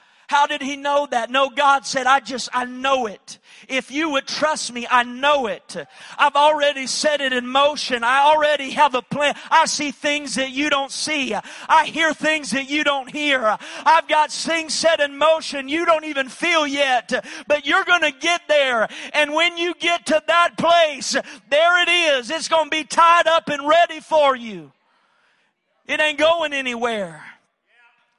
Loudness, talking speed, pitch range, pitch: -18 LUFS, 185 wpm, 265-315 Hz, 290 Hz